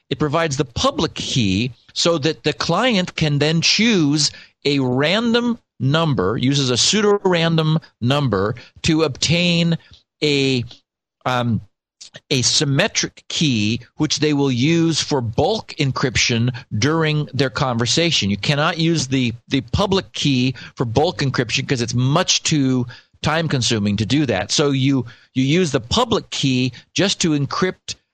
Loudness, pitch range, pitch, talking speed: -18 LUFS, 125-160 Hz, 140 Hz, 140 wpm